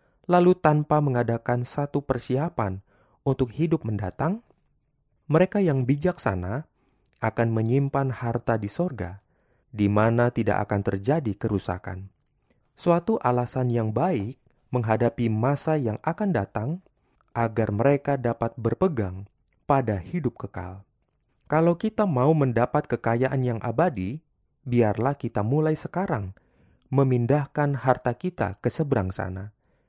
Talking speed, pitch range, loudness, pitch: 110 wpm, 110-145 Hz, -25 LUFS, 125 Hz